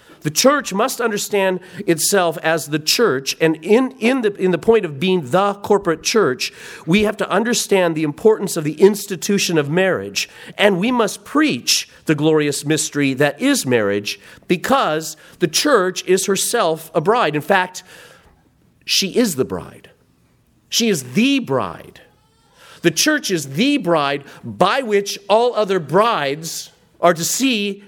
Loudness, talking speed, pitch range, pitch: -17 LUFS, 155 wpm, 160-215 Hz, 185 Hz